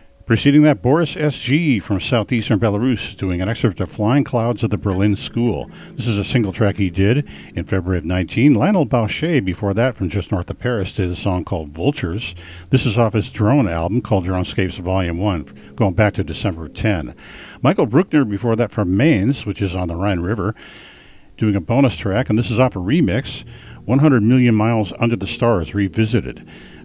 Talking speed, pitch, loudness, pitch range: 195 wpm, 105 Hz, -18 LUFS, 95-125 Hz